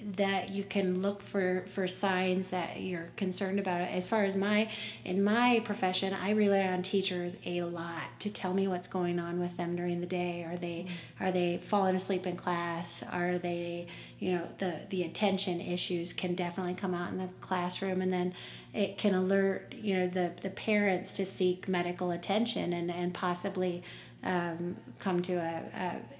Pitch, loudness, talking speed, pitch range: 180 Hz, -33 LUFS, 185 wpm, 175-195 Hz